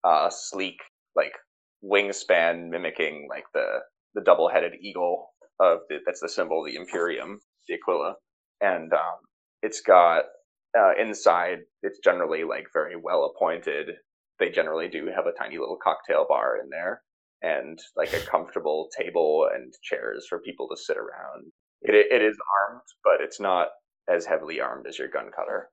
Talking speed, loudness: 160 wpm, -25 LUFS